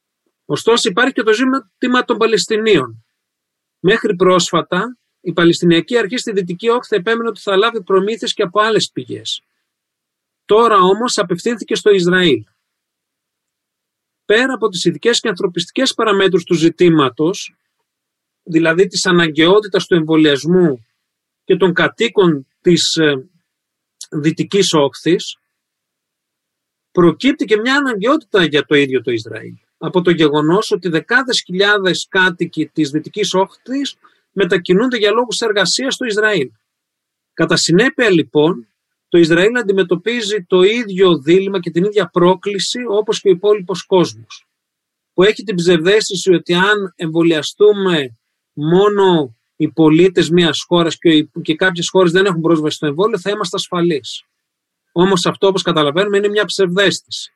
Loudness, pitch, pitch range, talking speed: -14 LUFS, 185 Hz, 165-210 Hz, 130 wpm